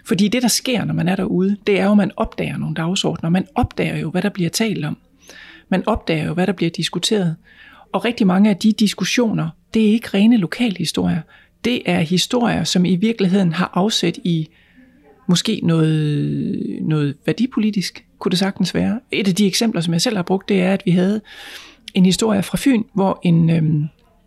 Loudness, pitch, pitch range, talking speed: -18 LUFS, 190 Hz, 170-215 Hz, 200 wpm